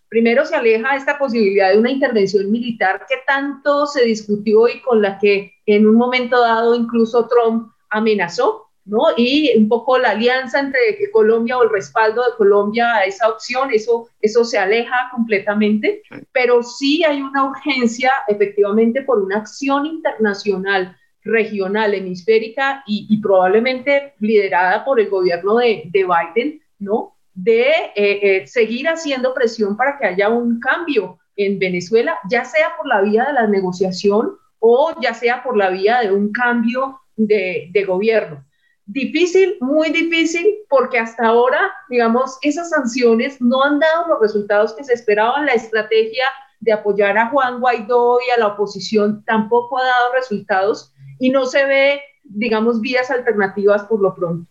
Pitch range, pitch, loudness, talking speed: 210-265 Hz, 230 Hz, -16 LUFS, 155 wpm